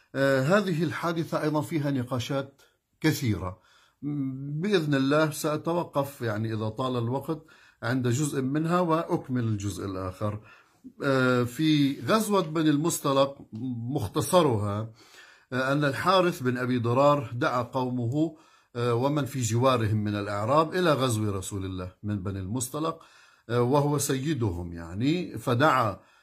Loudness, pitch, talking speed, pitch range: -27 LUFS, 135 Hz, 110 wpm, 115-155 Hz